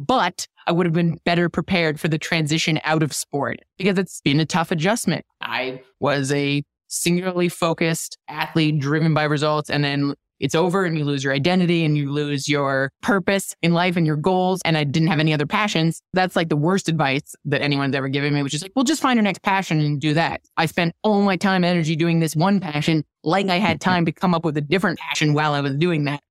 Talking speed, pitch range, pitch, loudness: 235 wpm, 150-180 Hz, 160 Hz, -21 LUFS